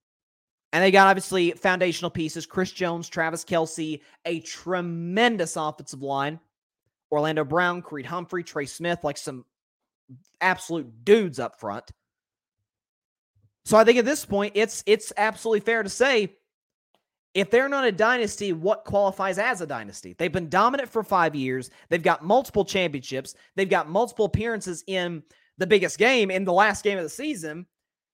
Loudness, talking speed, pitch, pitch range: -24 LUFS, 155 wpm, 180 Hz, 155-205 Hz